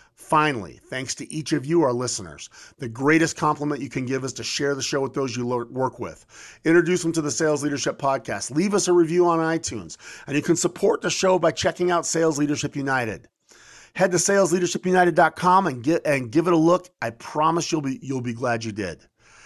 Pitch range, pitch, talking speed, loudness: 130-170 Hz, 150 Hz, 215 wpm, -22 LUFS